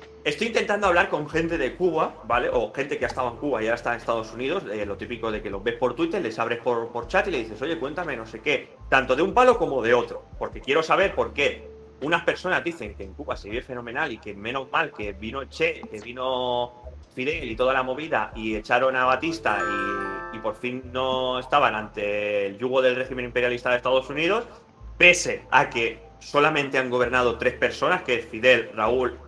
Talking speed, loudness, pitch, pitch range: 225 wpm, -24 LUFS, 125 Hz, 115-145 Hz